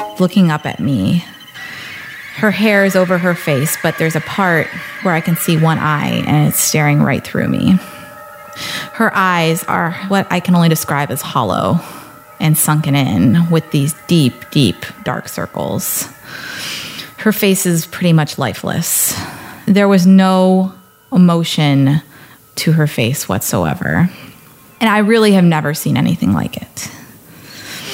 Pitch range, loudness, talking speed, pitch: 150-190 Hz, -14 LUFS, 145 wpm, 170 Hz